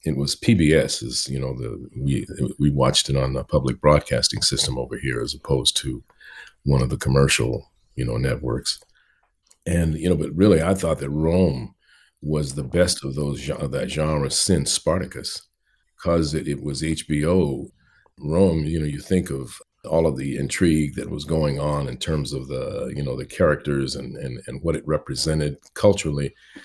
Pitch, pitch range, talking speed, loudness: 75 Hz, 70-80 Hz, 180 wpm, -22 LUFS